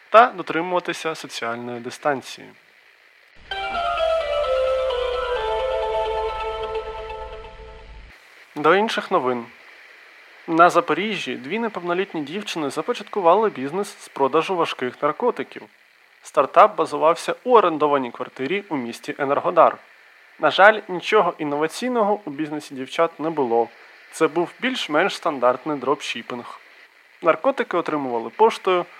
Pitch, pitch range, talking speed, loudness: 170 Hz, 145-220 Hz, 90 wpm, -21 LUFS